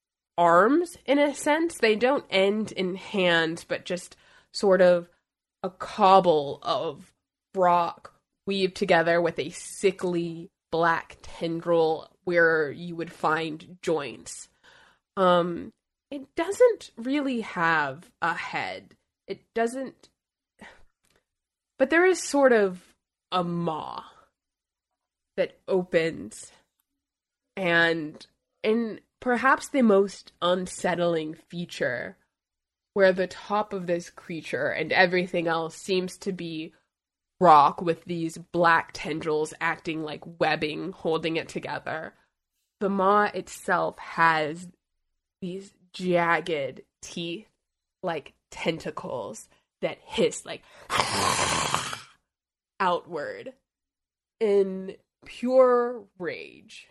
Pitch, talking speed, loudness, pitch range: 185 Hz, 100 wpm, -25 LUFS, 170-230 Hz